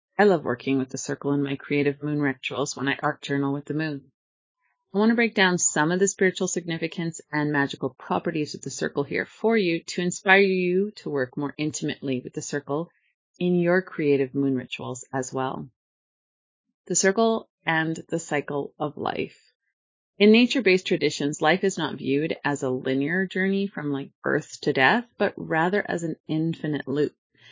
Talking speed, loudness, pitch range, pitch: 180 wpm, -24 LUFS, 140-185 Hz, 150 Hz